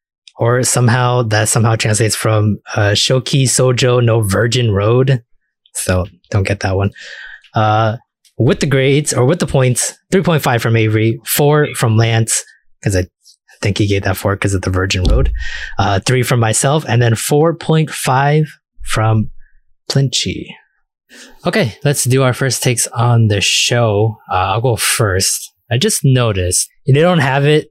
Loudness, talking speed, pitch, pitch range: -14 LUFS, 155 wpm, 115 Hz, 105-130 Hz